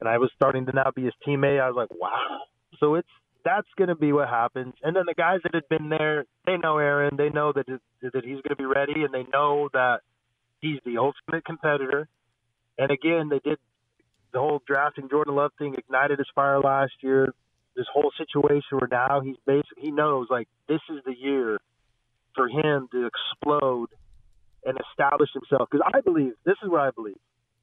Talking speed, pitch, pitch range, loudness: 205 wpm, 140 Hz, 130-150 Hz, -25 LUFS